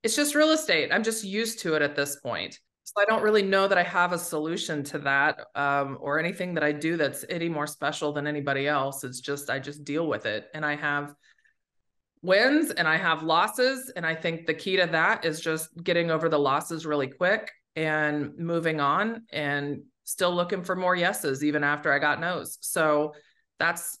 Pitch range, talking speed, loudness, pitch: 145-180 Hz, 210 wpm, -26 LUFS, 160 Hz